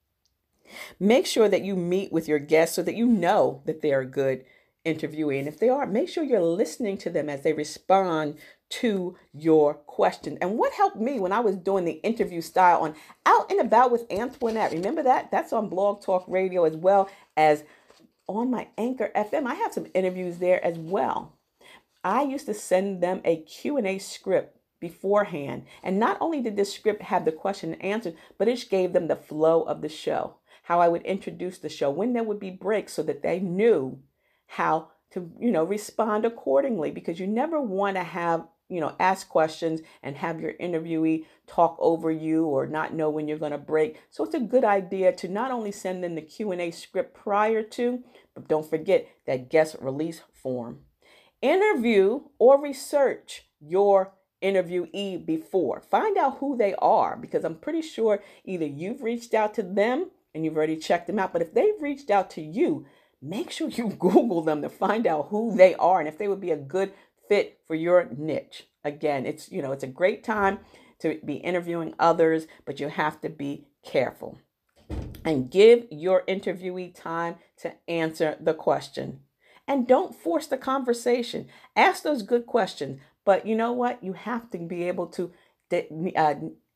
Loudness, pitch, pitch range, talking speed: -25 LUFS, 185 Hz, 160-225 Hz, 190 wpm